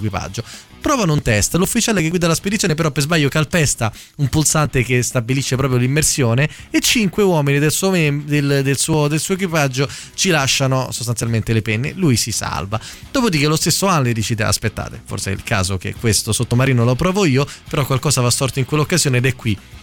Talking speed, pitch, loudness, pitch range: 195 wpm, 140 Hz, -17 LUFS, 115-155 Hz